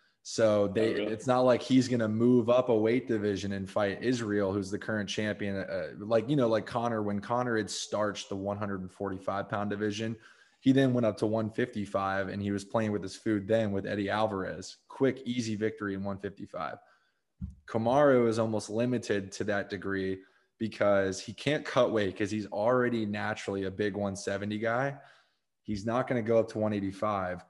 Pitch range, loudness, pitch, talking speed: 100-115 Hz, -30 LUFS, 105 Hz, 185 wpm